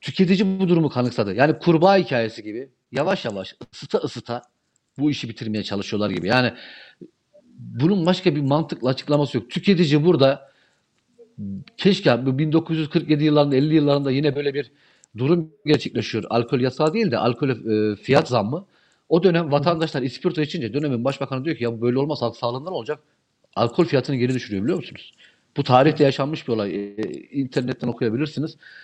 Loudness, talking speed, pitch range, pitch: -21 LUFS, 150 wpm, 120-160 Hz, 140 Hz